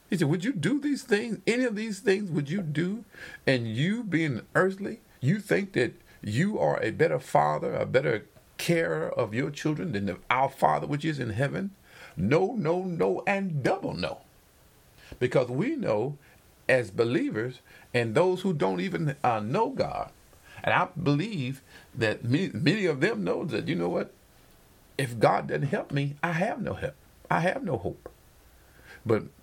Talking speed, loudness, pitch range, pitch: 175 wpm, -28 LUFS, 140-195 Hz, 165 Hz